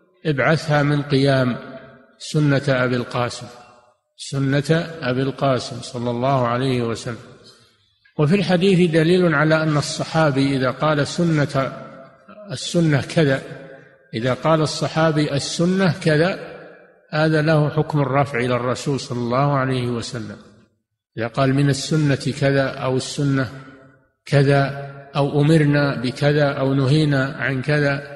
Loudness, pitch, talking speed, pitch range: -19 LUFS, 140 Hz, 115 wpm, 130-155 Hz